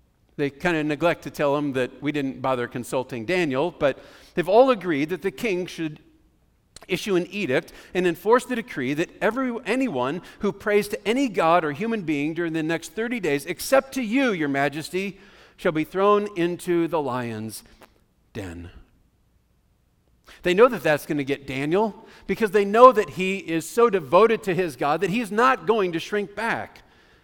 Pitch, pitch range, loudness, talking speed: 180 Hz, 150-215 Hz, -23 LUFS, 180 wpm